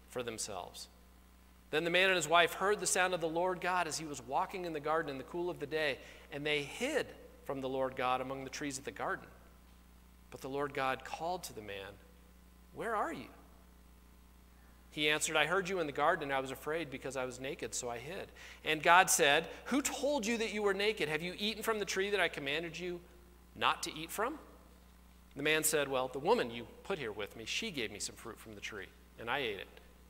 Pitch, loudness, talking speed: 140 Hz, -35 LUFS, 235 wpm